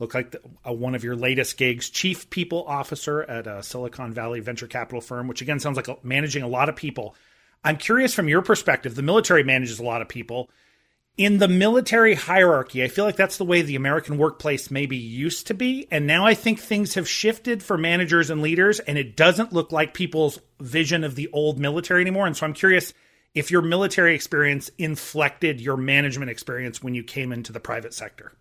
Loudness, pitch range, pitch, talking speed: -22 LUFS, 125-180 Hz, 150 Hz, 210 wpm